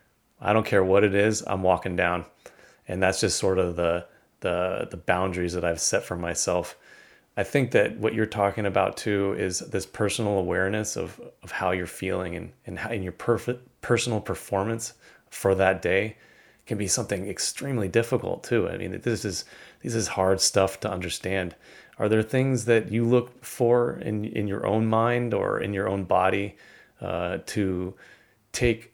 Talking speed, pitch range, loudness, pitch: 180 wpm, 95-115 Hz, -26 LUFS, 105 Hz